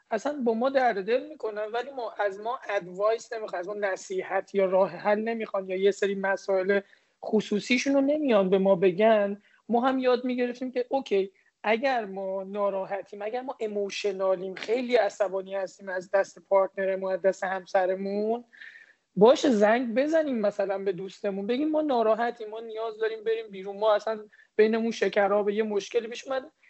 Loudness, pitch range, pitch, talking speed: -27 LUFS, 195-240 Hz, 210 Hz, 160 wpm